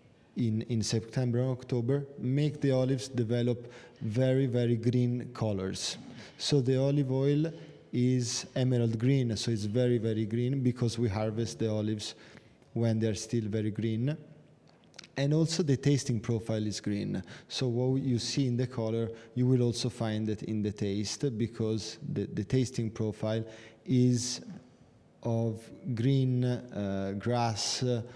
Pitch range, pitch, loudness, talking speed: 110-130 Hz, 120 Hz, -31 LUFS, 145 wpm